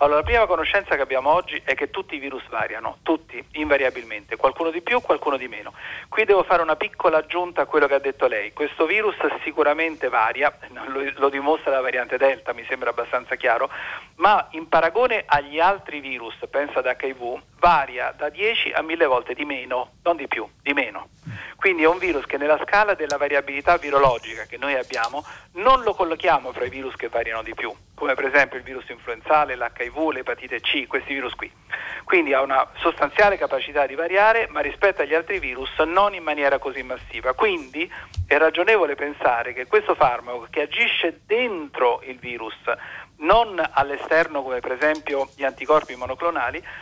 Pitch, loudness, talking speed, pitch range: 150 Hz, -22 LUFS, 180 wpm, 135-180 Hz